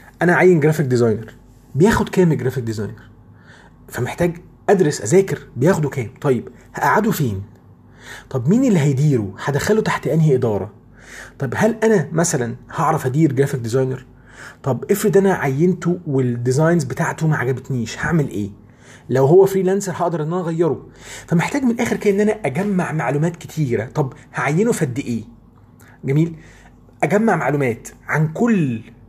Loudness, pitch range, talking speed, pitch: -18 LUFS, 125-175 Hz, 140 wpm, 145 Hz